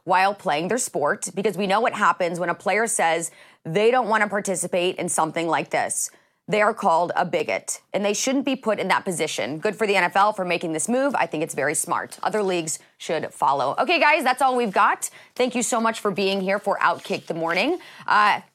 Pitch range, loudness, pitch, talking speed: 180-230 Hz, -22 LUFS, 200 Hz, 225 wpm